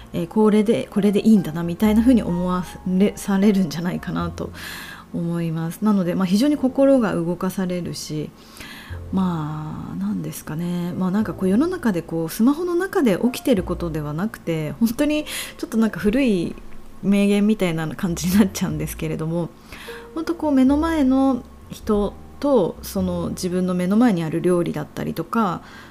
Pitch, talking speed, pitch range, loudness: 195 Hz, 365 characters per minute, 170-230 Hz, -21 LUFS